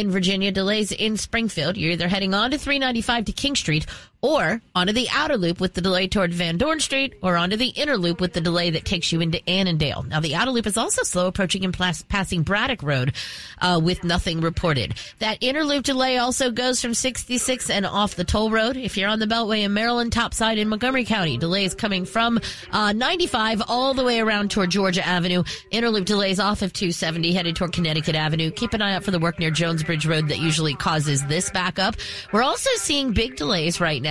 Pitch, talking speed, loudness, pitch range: 195 Hz, 220 wpm, -22 LUFS, 170-230 Hz